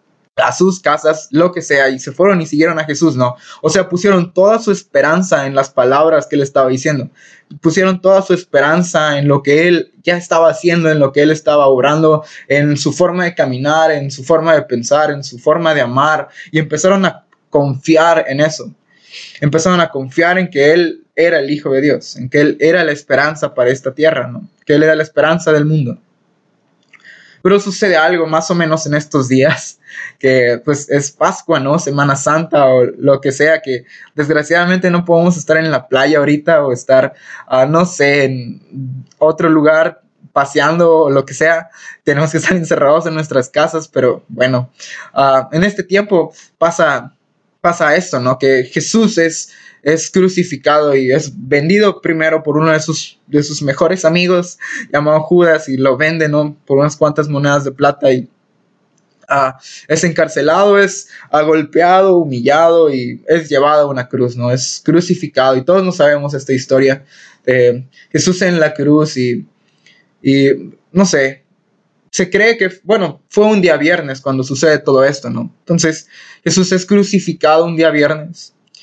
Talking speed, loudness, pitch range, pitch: 175 wpm, -12 LUFS, 140-170 Hz, 155 Hz